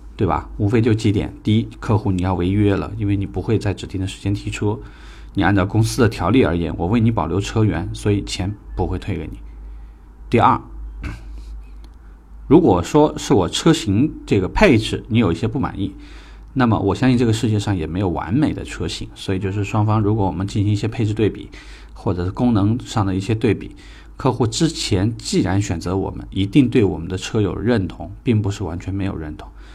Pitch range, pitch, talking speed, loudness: 90-110 Hz, 100 Hz, 305 characters per minute, -19 LUFS